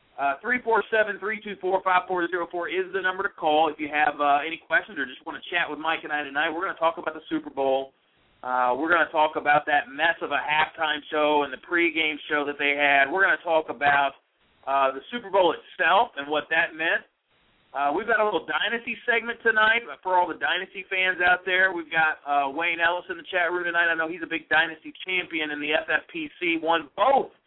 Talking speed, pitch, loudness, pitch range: 220 wpm, 165 Hz, -24 LUFS, 150-185 Hz